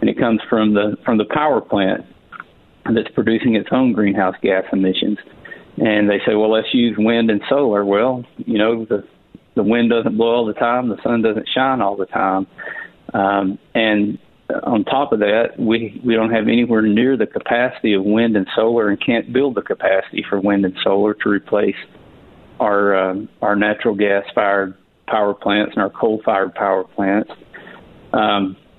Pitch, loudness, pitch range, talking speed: 105 Hz, -17 LUFS, 100-115 Hz, 175 wpm